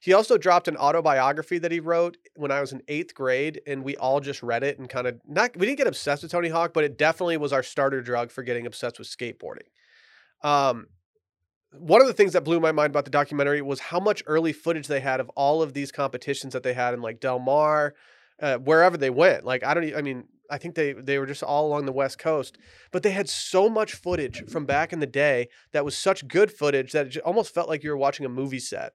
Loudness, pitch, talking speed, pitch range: -24 LUFS, 145 Hz, 250 wpm, 135-165 Hz